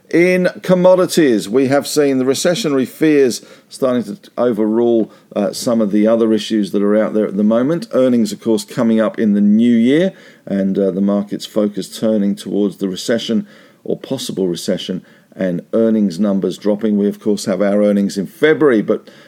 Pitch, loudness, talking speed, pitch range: 110 Hz, -15 LUFS, 180 wpm, 100-140 Hz